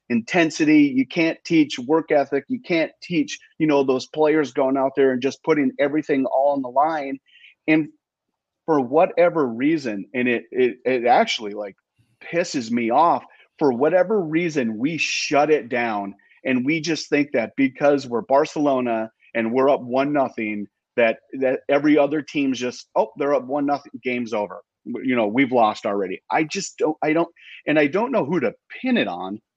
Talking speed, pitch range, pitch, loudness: 180 wpm, 130-165 Hz, 145 Hz, -21 LUFS